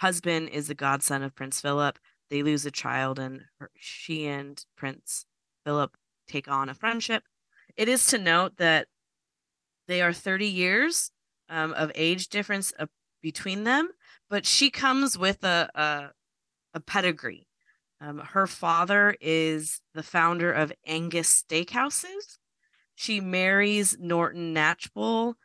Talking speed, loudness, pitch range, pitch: 135 wpm, -25 LUFS, 150-205 Hz, 170 Hz